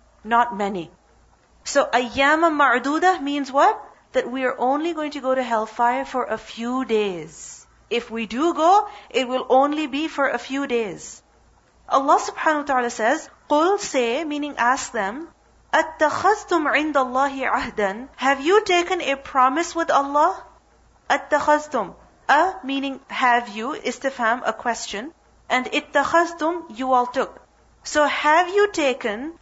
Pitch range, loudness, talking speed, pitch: 245-315 Hz, -21 LUFS, 145 wpm, 275 Hz